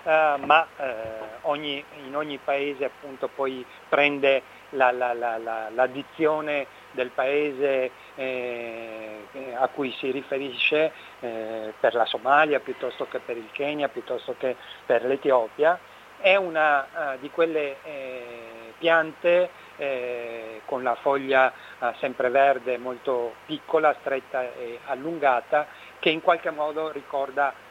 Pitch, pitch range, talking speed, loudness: 140 Hz, 125-150 Hz, 130 wpm, -25 LUFS